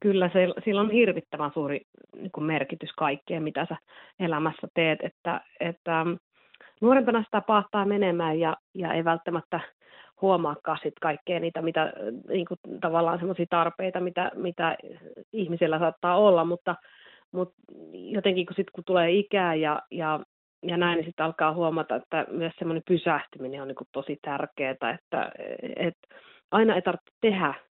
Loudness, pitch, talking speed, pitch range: -27 LUFS, 170 Hz, 140 wpm, 155-185 Hz